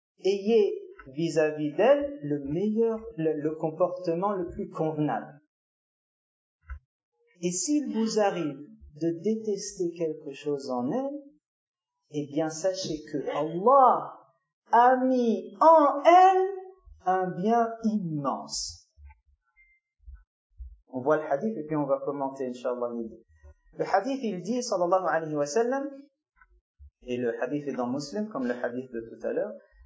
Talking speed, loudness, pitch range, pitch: 130 wpm, -27 LUFS, 135-230 Hz, 165 Hz